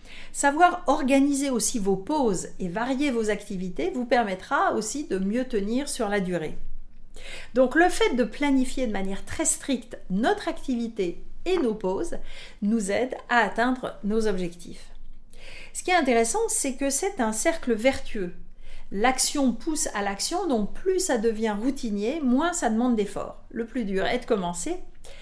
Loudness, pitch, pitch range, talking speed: -25 LUFS, 240 Hz, 210-280 Hz, 160 wpm